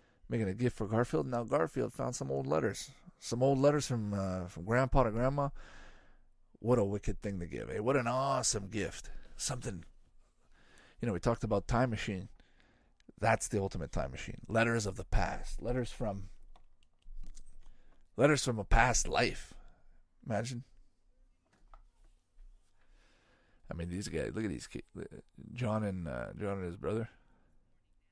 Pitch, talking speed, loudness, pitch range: 105 Hz, 155 wpm, -34 LUFS, 90-120 Hz